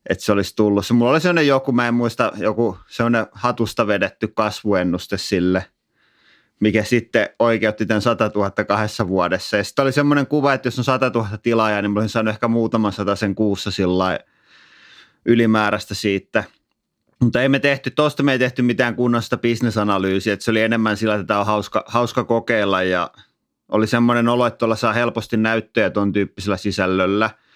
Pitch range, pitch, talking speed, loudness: 100-120 Hz, 110 Hz, 180 wpm, -19 LUFS